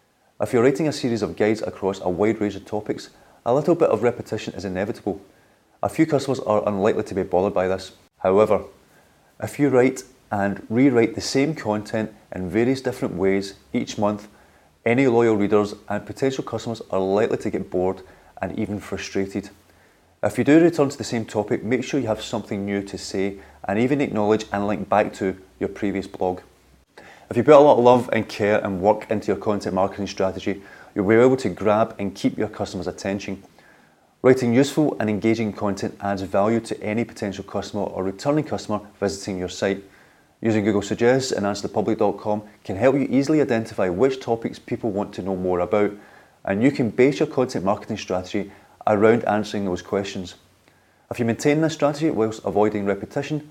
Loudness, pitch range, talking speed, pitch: -22 LUFS, 100-120 Hz, 185 wpm, 105 Hz